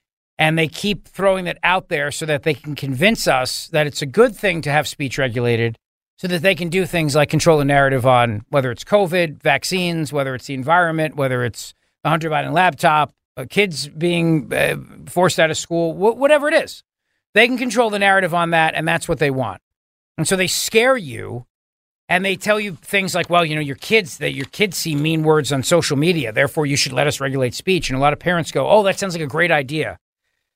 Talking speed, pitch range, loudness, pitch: 225 wpm, 140-185 Hz, -18 LUFS, 160 Hz